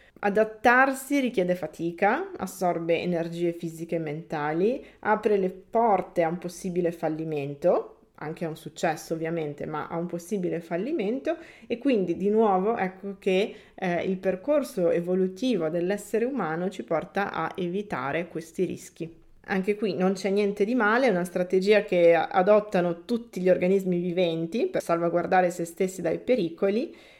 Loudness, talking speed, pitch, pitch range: -26 LUFS, 145 wpm, 185 Hz, 170-205 Hz